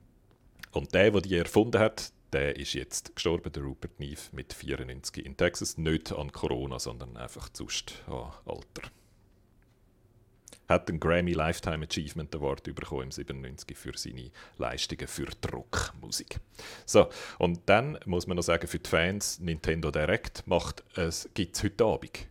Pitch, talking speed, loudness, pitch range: 80 Hz, 150 wpm, -31 LUFS, 70-90 Hz